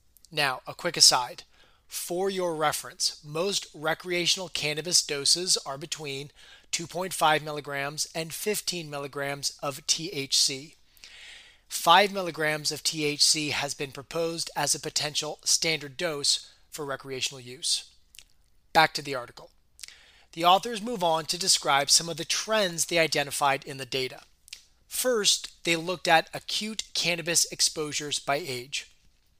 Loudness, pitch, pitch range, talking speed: -26 LUFS, 155 Hz, 140-175 Hz, 130 wpm